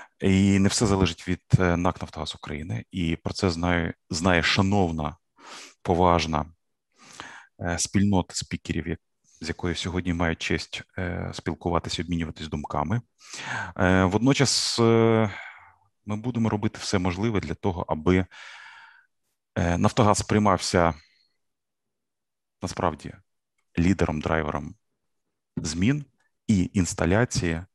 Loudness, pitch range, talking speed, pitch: -25 LUFS, 85-105 Hz, 90 wpm, 90 Hz